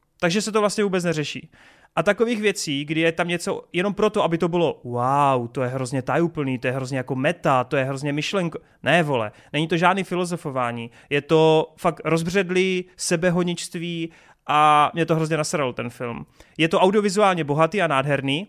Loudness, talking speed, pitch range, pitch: -22 LUFS, 180 wpm, 140-180 Hz, 165 Hz